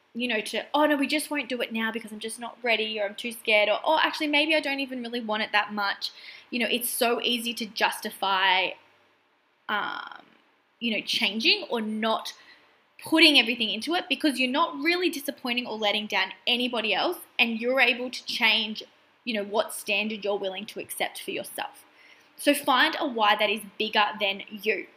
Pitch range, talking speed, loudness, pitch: 215-280 Hz, 200 wpm, -25 LUFS, 235 Hz